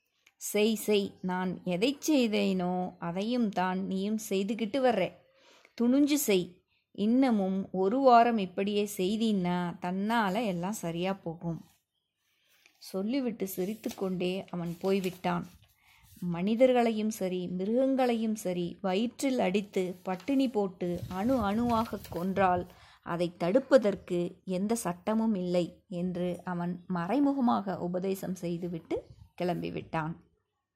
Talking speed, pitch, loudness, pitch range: 95 wpm, 190 Hz, -30 LUFS, 180-225 Hz